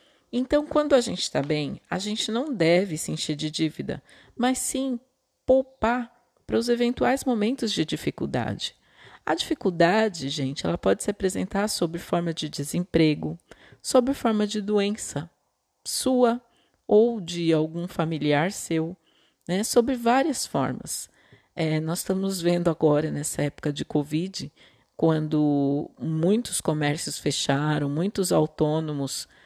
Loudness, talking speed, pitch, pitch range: -25 LUFS, 130 wpm, 175 Hz, 155-235 Hz